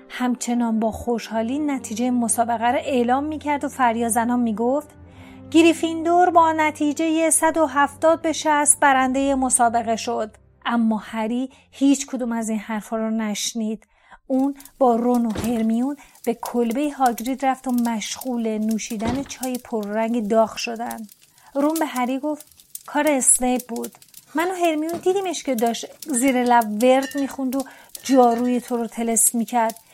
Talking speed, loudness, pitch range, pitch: 140 wpm, -21 LUFS, 230-285 Hz, 250 Hz